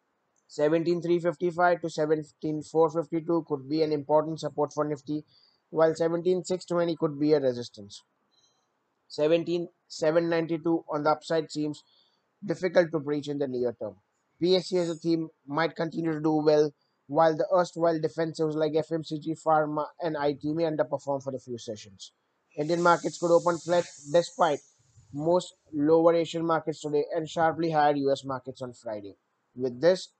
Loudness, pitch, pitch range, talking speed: -27 LUFS, 160 Hz, 150-170 Hz, 145 wpm